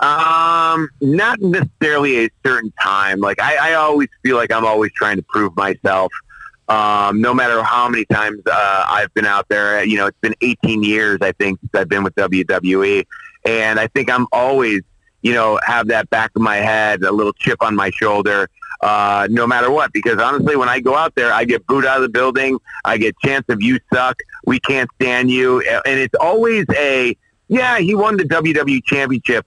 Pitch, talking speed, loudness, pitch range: 125 Hz, 200 wpm, -15 LUFS, 110-145 Hz